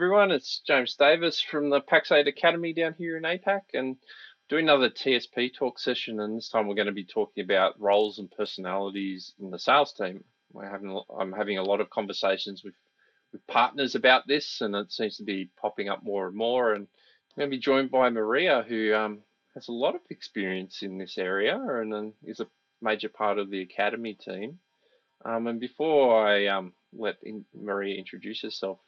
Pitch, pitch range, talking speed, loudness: 110 Hz, 100-135 Hz, 195 wpm, -27 LUFS